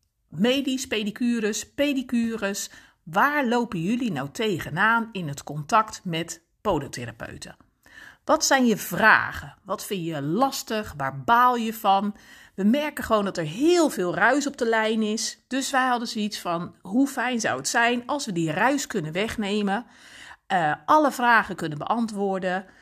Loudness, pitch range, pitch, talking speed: -24 LUFS, 195-250 Hz, 220 Hz, 155 wpm